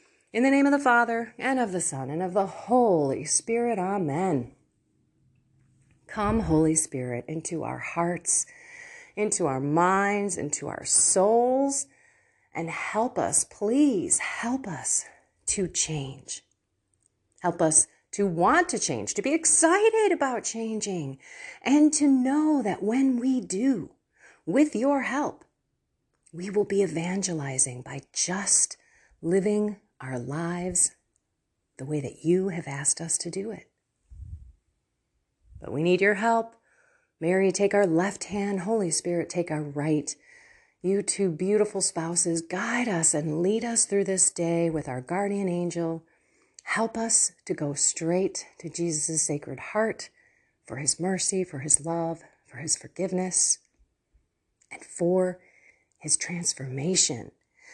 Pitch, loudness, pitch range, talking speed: 180 Hz, -25 LUFS, 155-225 Hz, 135 wpm